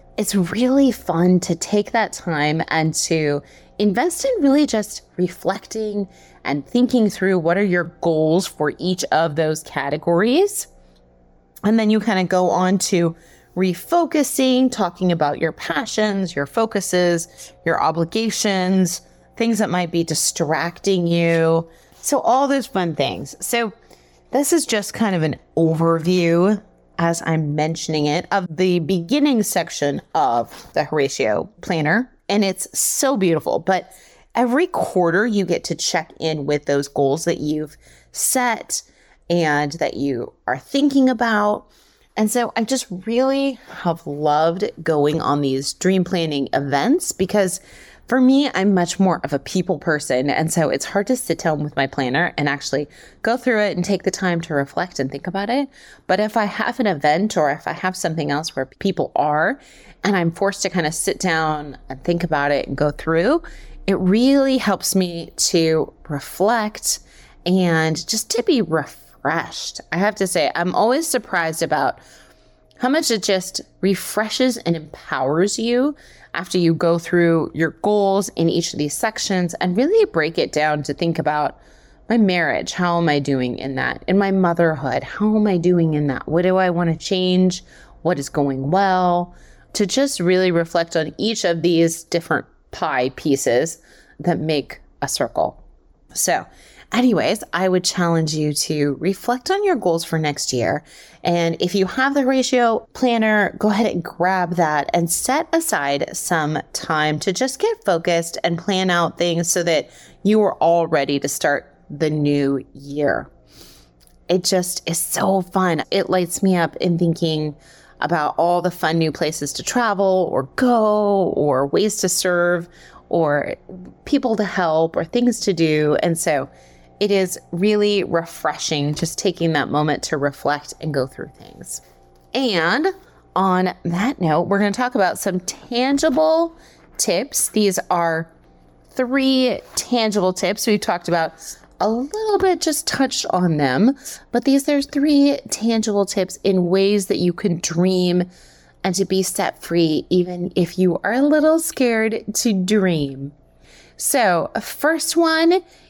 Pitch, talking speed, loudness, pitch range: 180 Hz, 160 wpm, -19 LUFS, 160-215 Hz